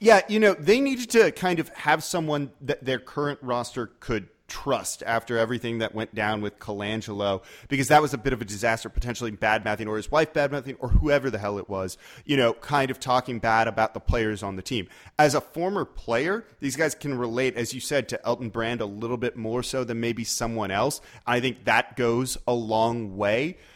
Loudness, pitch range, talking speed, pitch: -26 LUFS, 110-145 Hz, 220 wpm, 120 Hz